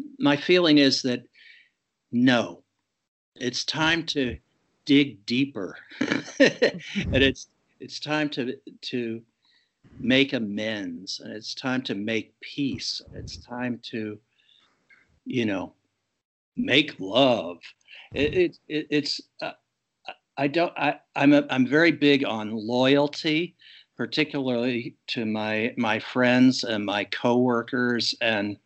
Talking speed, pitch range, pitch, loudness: 115 wpm, 115-150 Hz, 130 Hz, -24 LUFS